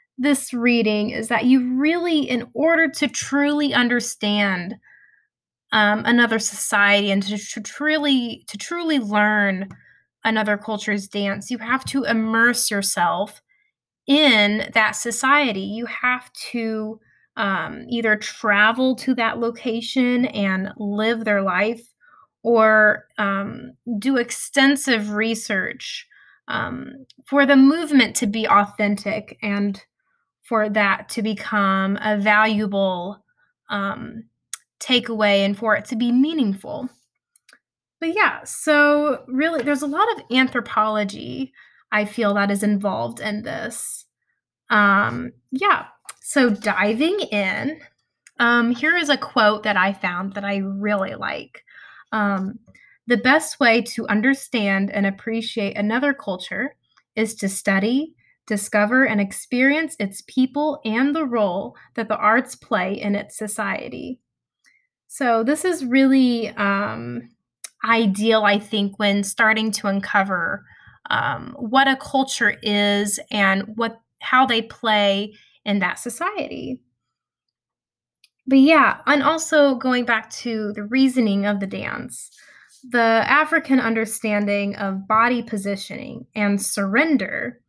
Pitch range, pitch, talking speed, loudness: 205-265 Hz, 225 Hz, 120 wpm, -20 LUFS